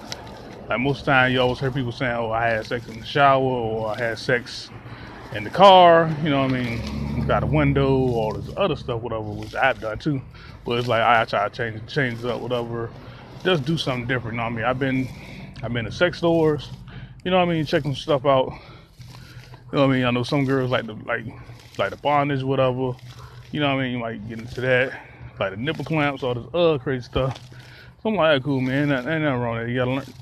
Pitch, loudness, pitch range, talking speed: 130 Hz, -22 LUFS, 120-140 Hz, 255 wpm